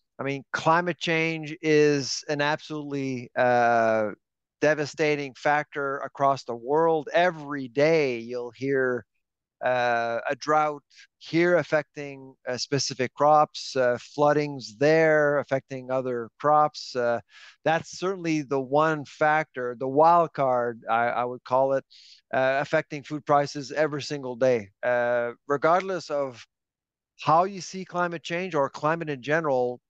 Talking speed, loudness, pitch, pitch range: 130 wpm, -25 LUFS, 145 Hz, 125-155 Hz